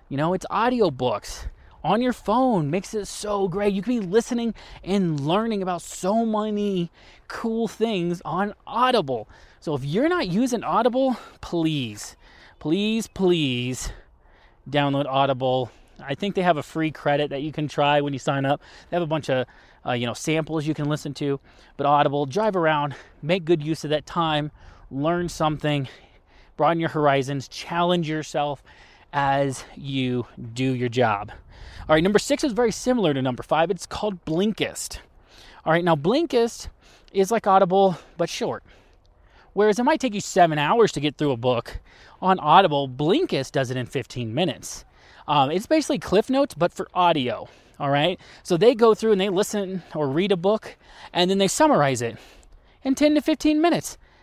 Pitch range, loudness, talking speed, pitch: 140-205 Hz, -23 LUFS, 175 wpm, 165 Hz